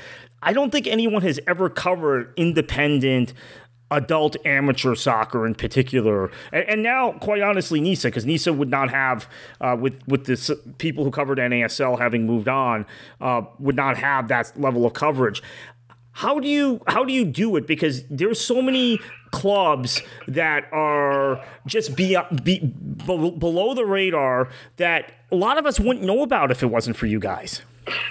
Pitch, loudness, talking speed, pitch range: 145 Hz, -21 LUFS, 170 wpm, 125-180 Hz